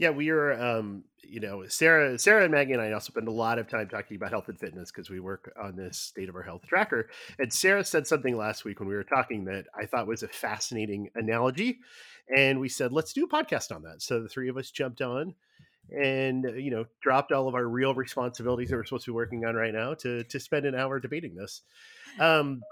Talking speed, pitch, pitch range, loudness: 245 wpm, 125 Hz, 110-140 Hz, -28 LUFS